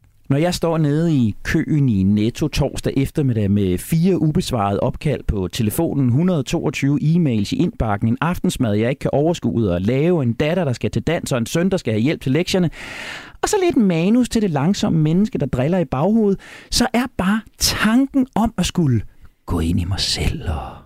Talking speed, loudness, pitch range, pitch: 195 wpm, -19 LUFS, 115-180 Hz, 145 Hz